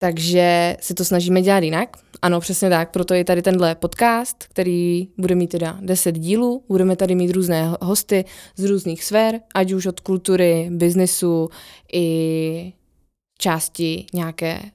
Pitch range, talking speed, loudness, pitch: 170-190 Hz, 145 wpm, -19 LUFS, 180 Hz